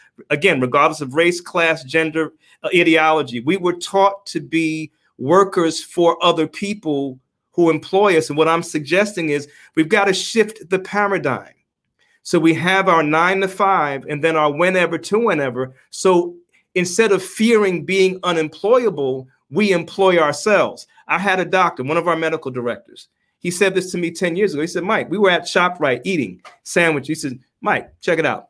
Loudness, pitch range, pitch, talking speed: -17 LUFS, 155-190 Hz, 175 Hz, 180 wpm